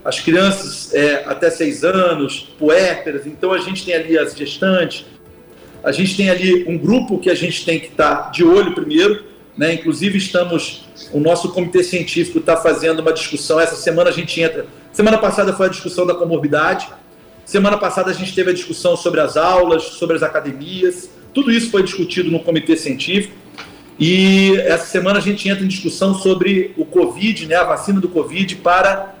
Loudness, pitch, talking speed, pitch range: -16 LUFS, 175 Hz, 185 wpm, 160-190 Hz